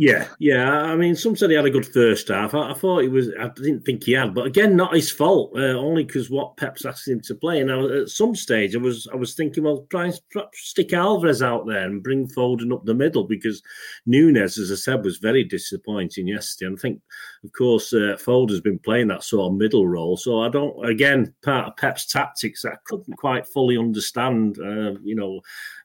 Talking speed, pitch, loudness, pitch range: 230 wpm, 125 Hz, -21 LUFS, 110-150 Hz